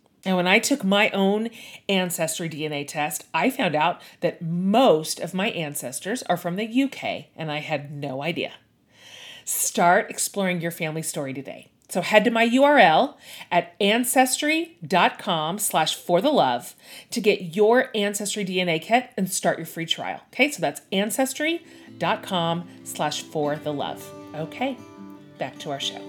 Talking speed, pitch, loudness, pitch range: 145 wpm, 180 Hz, -23 LUFS, 155-225 Hz